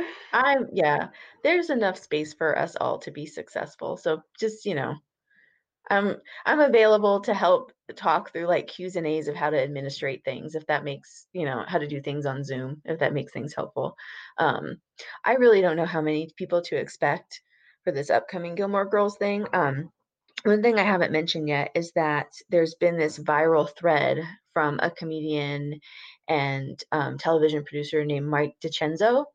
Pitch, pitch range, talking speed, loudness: 165 Hz, 150-205 Hz, 180 wpm, -25 LUFS